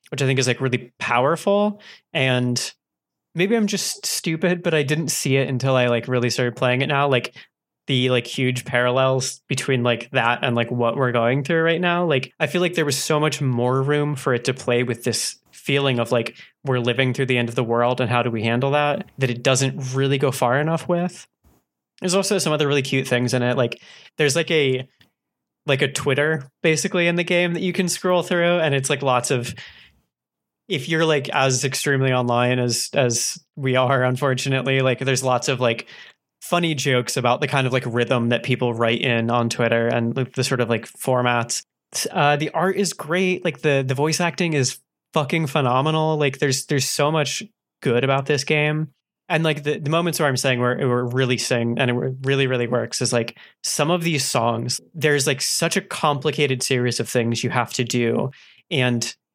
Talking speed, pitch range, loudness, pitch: 210 wpm, 125-155 Hz, -21 LUFS, 135 Hz